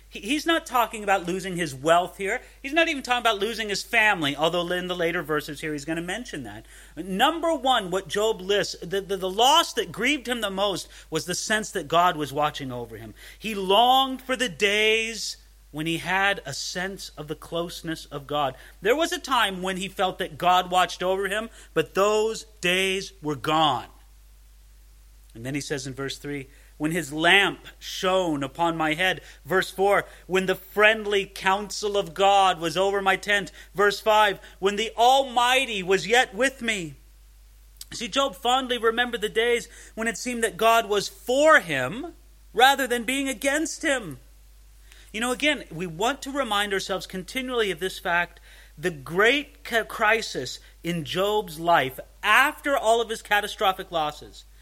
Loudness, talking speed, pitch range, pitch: -24 LUFS, 175 wpm, 165-225 Hz, 195 Hz